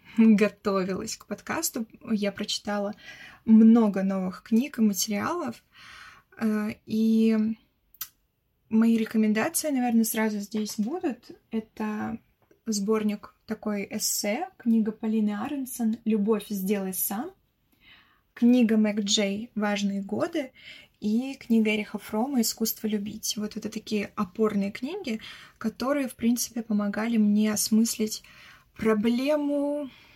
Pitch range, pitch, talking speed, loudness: 210-235 Hz, 220 Hz, 100 wpm, -26 LUFS